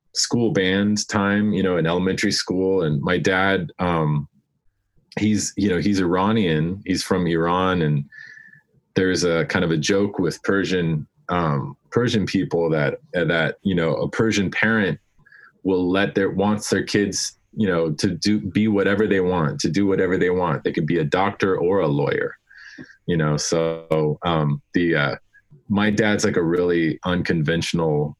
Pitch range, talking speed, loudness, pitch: 80-100 Hz, 165 wpm, -21 LUFS, 95 Hz